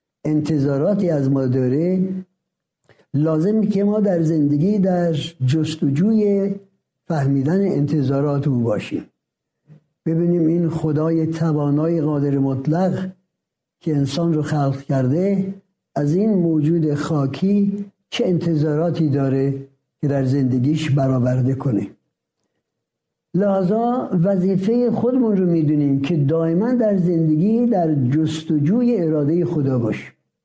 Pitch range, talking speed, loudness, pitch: 145-185 Hz, 100 wpm, -19 LUFS, 160 Hz